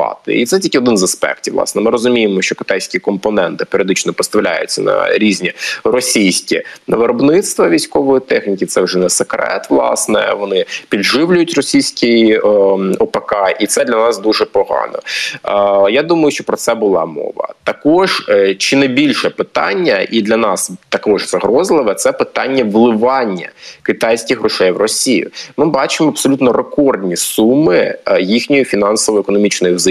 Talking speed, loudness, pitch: 135 wpm, -13 LUFS, 125 Hz